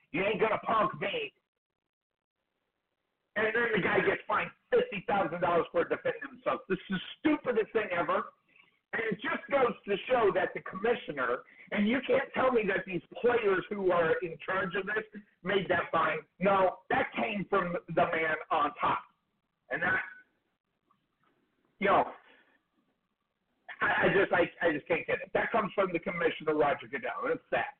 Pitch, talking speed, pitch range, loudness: 205 Hz, 170 wpm, 180-250 Hz, -30 LUFS